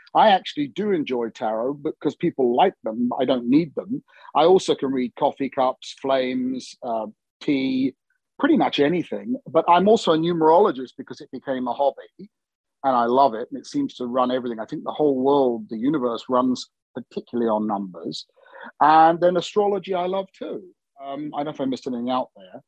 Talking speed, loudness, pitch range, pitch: 190 wpm, -22 LUFS, 130-195 Hz, 145 Hz